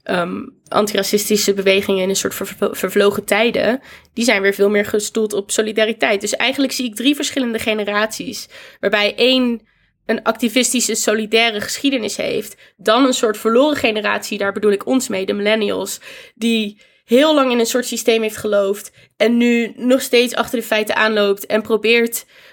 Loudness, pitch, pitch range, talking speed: -17 LUFS, 220 Hz, 205-240 Hz, 165 wpm